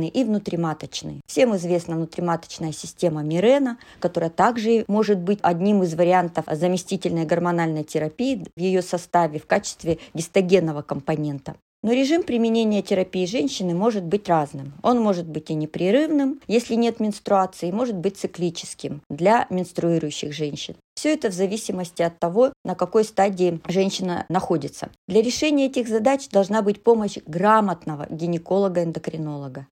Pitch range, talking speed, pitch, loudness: 165-220 Hz, 135 wpm, 185 Hz, -22 LUFS